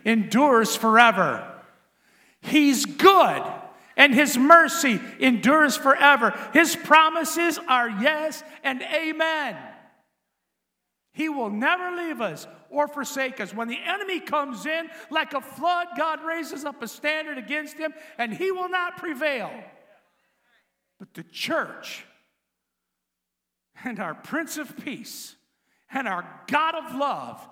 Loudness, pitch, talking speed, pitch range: -22 LUFS, 295 Hz, 120 wpm, 250-325 Hz